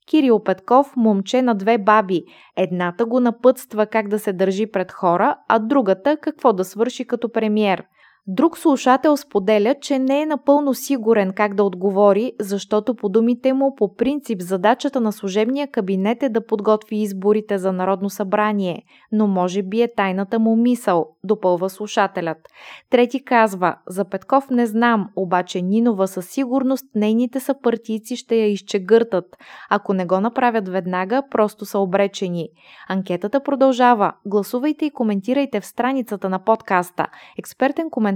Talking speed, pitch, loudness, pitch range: 145 wpm, 215 Hz, -19 LUFS, 195-250 Hz